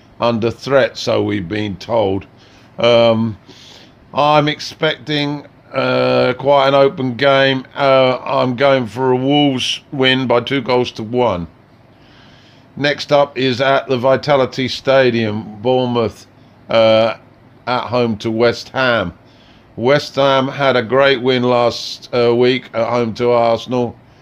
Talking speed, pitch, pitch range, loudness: 130 wpm, 125 Hz, 115-135 Hz, -15 LUFS